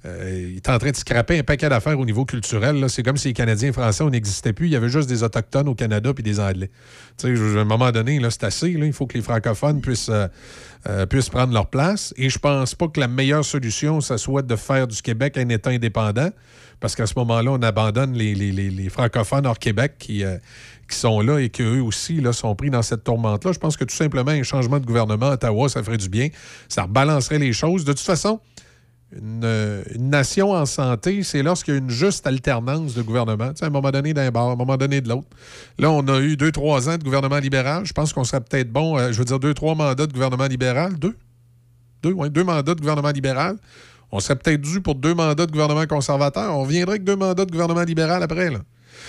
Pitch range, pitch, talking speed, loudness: 115-150 Hz, 135 Hz, 250 wpm, -21 LUFS